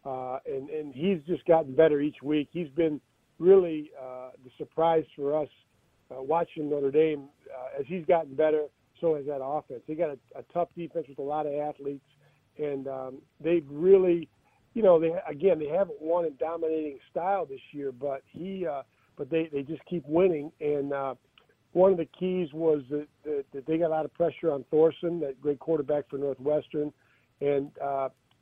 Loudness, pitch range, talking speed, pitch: -28 LUFS, 140-165 Hz, 190 wpm, 150 Hz